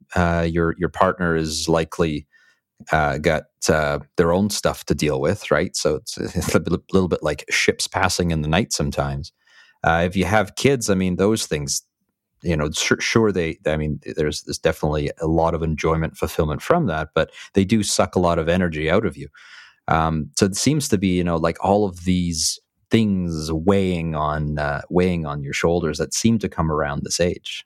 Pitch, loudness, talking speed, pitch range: 85 Hz, -21 LUFS, 200 wpm, 80-95 Hz